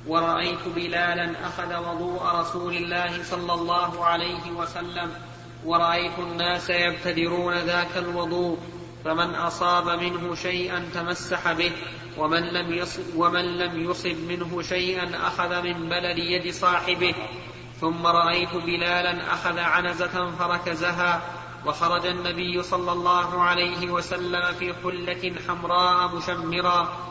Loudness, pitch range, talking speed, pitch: -25 LUFS, 170-175 Hz, 110 wpm, 175 Hz